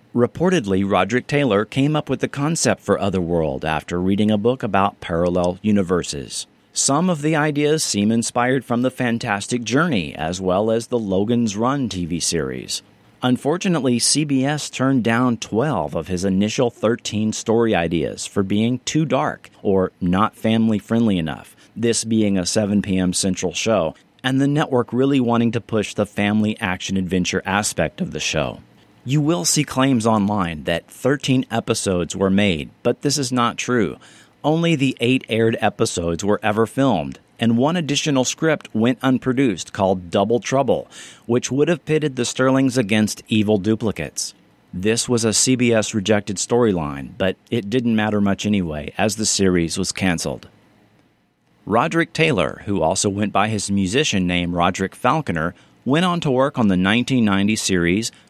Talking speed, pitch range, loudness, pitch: 160 wpm, 100-130 Hz, -20 LUFS, 110 Hz